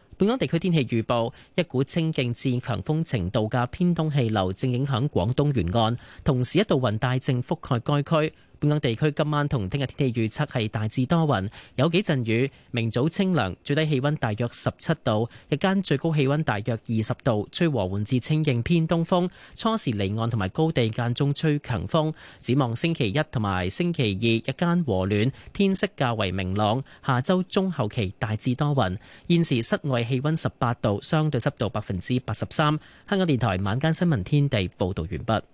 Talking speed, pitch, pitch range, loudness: 285 characters per minute, 130 Hz, 115-155 Hz, -25 LUFS